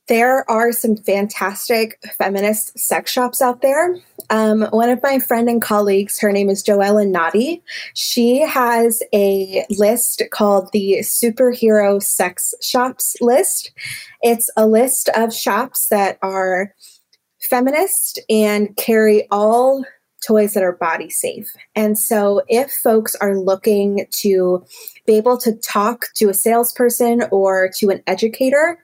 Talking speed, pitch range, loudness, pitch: 135 wpm, 200-245 Hz, -16 LUFS, 220 Hz